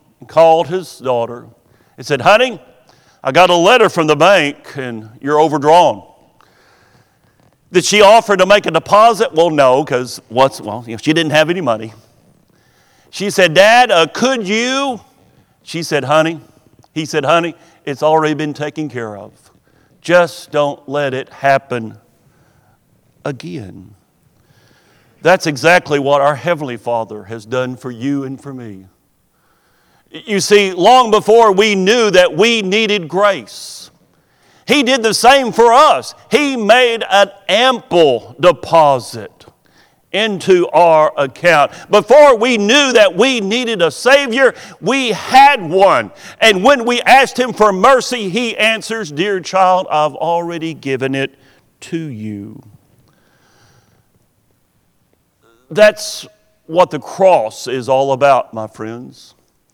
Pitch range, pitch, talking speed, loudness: 135-210 Hz, 165 Hz, 130 wpm, -12 LUFS